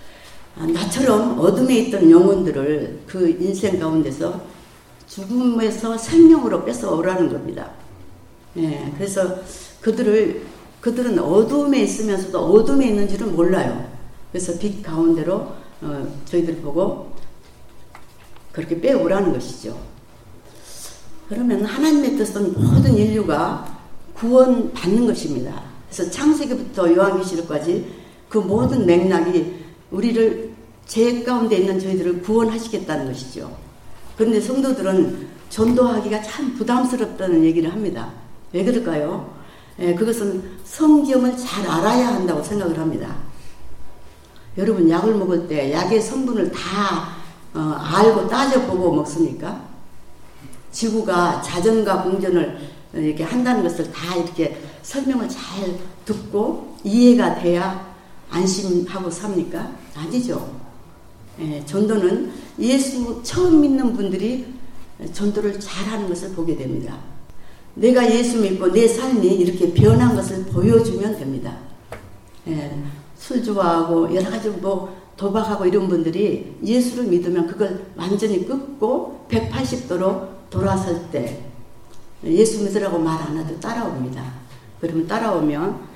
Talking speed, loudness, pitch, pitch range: 265 characters per minute, -19 LUFS, 190 Hz, 165-220 Hz